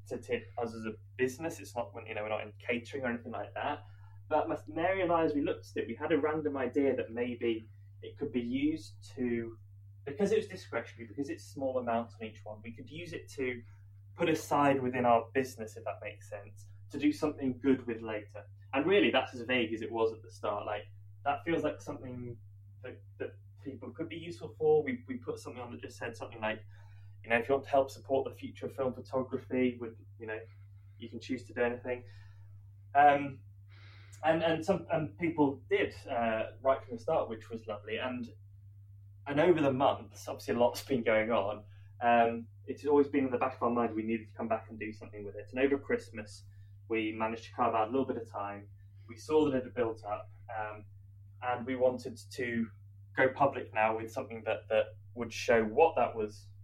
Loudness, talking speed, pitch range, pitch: -33 LUFS, 220 wpm, 100-130 Hz, 115 Hz